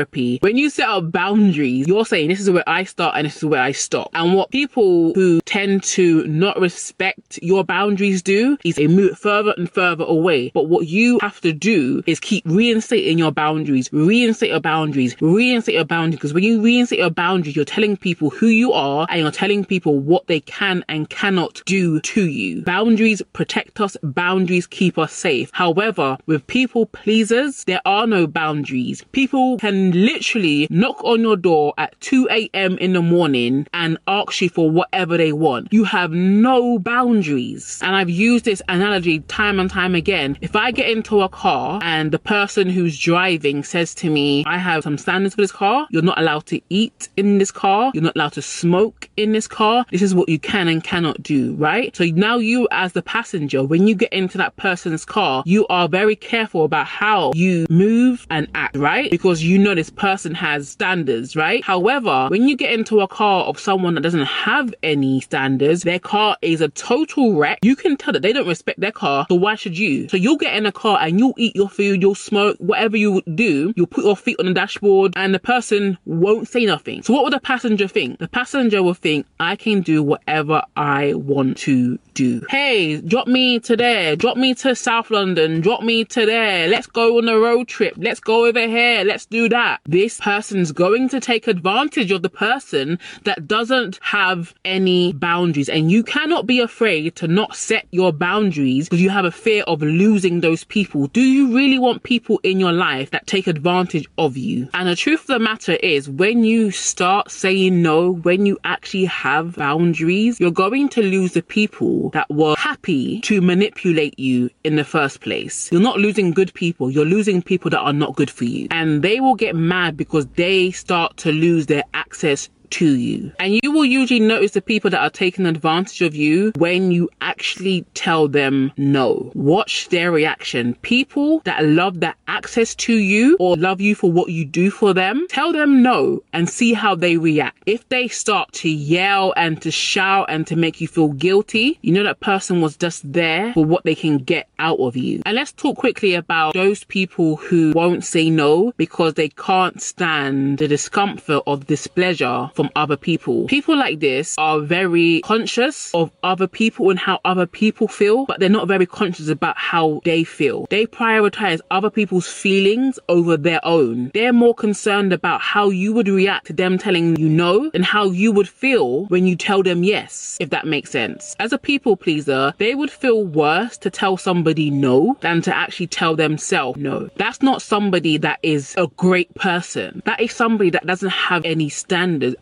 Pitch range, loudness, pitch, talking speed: 165-215 Hz, -17 LUFS, 185 Hz, 200 wpm